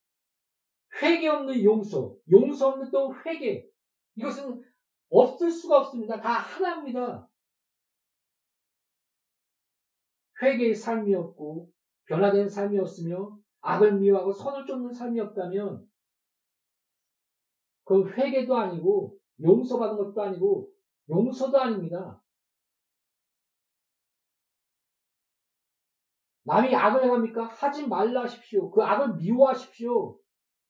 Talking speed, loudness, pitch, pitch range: 210 characters per minute, -25 LUFS, 240 Hz, 200-275 Hz